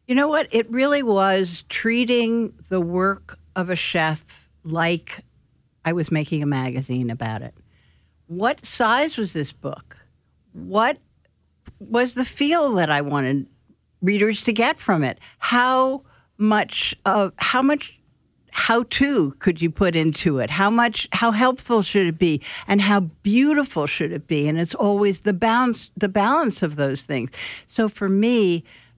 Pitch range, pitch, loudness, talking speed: 155-235 Hz, 195 Hz, -21 LUFS, 155 wpm